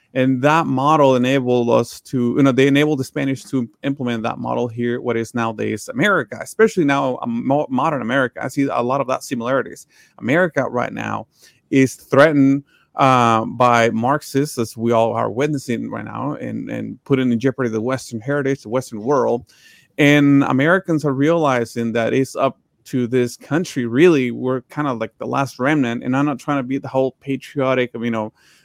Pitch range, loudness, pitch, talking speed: 120-140 Hz, -18 LUFS, 130 Hz, 185 wpm